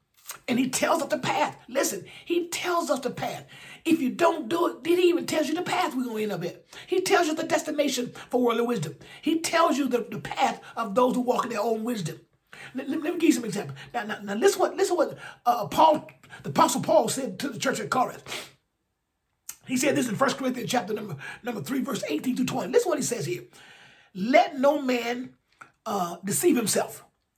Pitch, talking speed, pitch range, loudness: 255 Hz, 235 wpm, 230-320 Hz, -26 LUFS